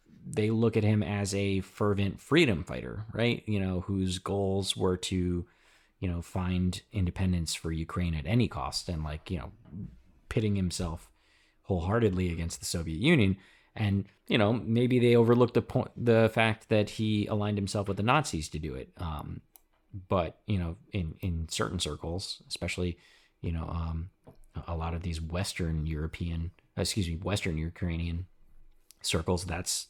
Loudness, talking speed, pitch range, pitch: -30 LUFS, 160 wpm, 85-105 Hz, 95 Hz